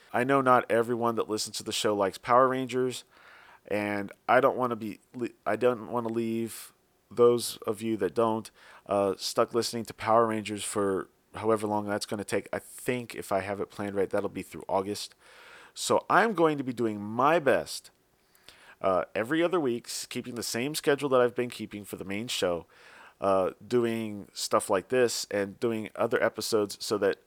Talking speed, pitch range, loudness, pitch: 195 wpm, 105-125 Hz, -28 LUFS, 115 Hz